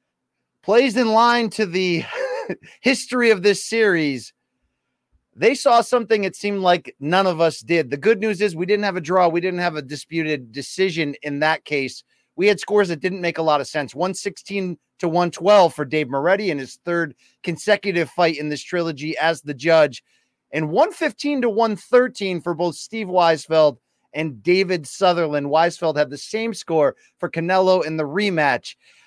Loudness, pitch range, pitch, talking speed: -20 LUFS, 155-210 Hz, 175 Hz, 175 wpm